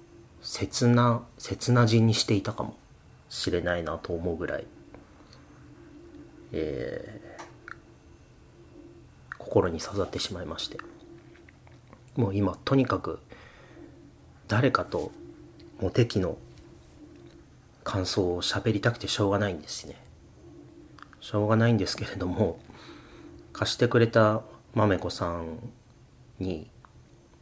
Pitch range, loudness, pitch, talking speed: 90-120 Hz, -28 LUFS, 105 Hz, 205 characters per minute